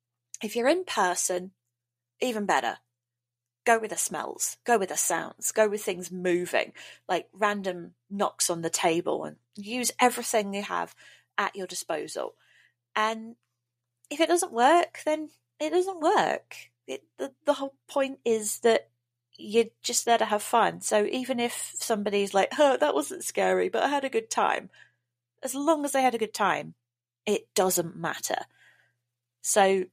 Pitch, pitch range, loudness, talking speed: 205 Hz, 165-240 Hz, -27 LUFS, 160 wpm